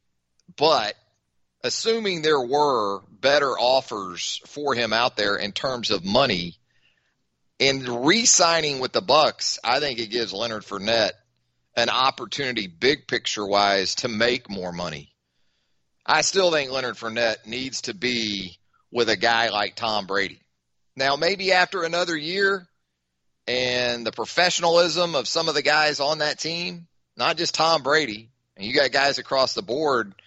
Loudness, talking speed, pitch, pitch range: -22 LUFS, 150 wpm, 120 Hz, 95-155 Hz